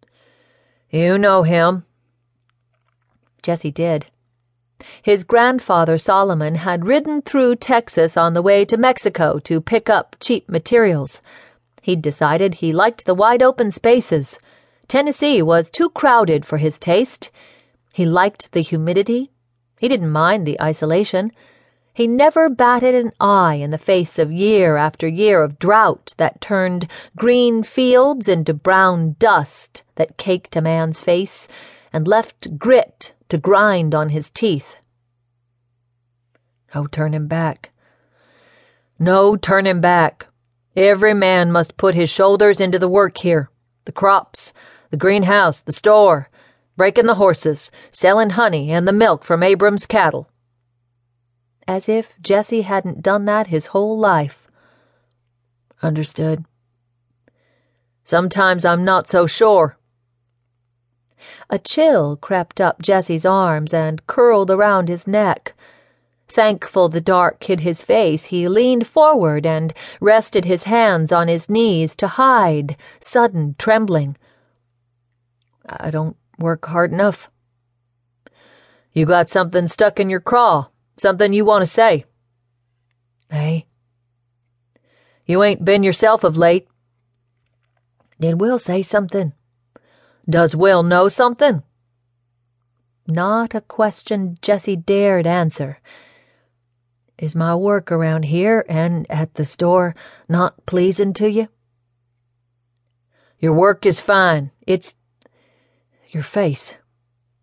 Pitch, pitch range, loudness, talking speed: 170 Hz, 135-200 Hz, -16 LUFS, 125 wpm